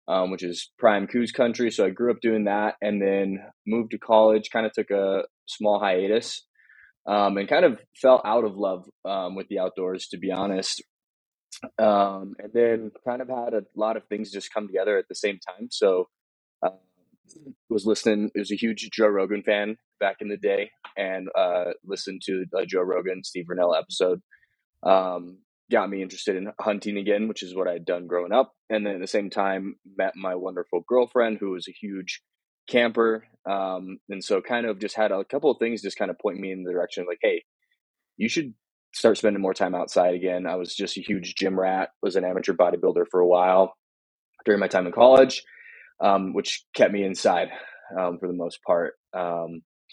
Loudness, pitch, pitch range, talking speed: -25 LUFS, 100 Hz, 95-110 Hz, 205 wpm